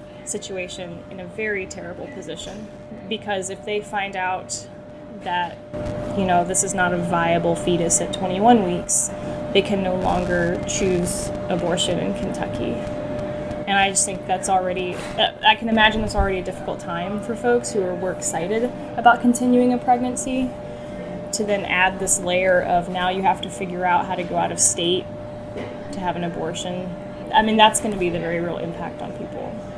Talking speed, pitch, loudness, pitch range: 180 wpm, 195 Hz, -21 LUFS, 180-215 Hz